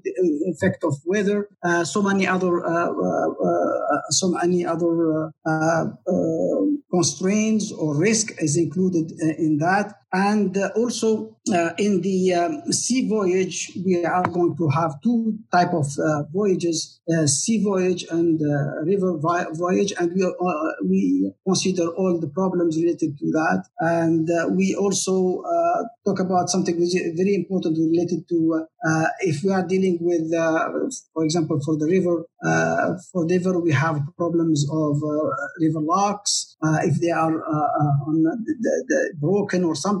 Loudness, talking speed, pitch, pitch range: -22 LUFS, 165 wpm, 175 Hz, 160-190 Hz